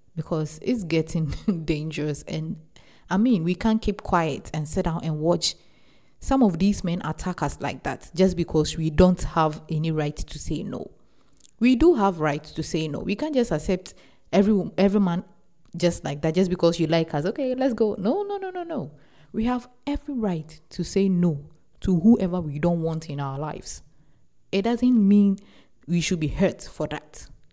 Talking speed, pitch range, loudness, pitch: 190 wpm, 160-205 Hz, -24 LUFS, 175 Hz